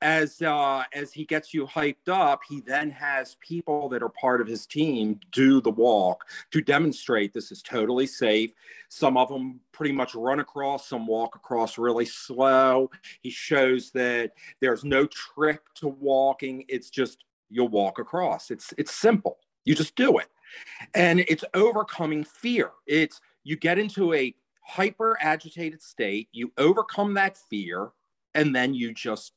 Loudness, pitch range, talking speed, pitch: -25 LUFS, 125-155 Hz, 160 wpm, 140 Hz